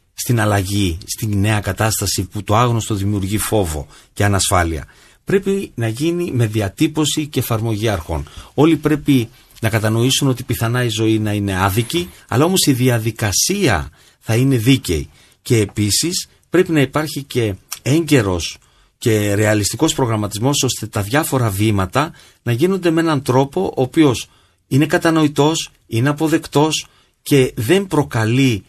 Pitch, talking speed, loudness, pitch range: 120 Hz, 140 wpm, -17 LUFS, 105-145 Hz